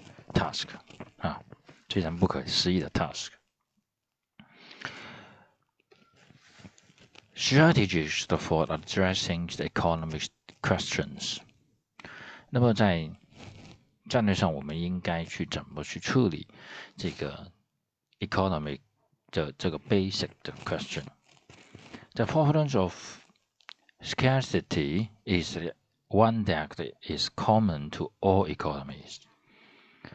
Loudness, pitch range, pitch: -29 LUFS, 80-110 Hz, 95 Hz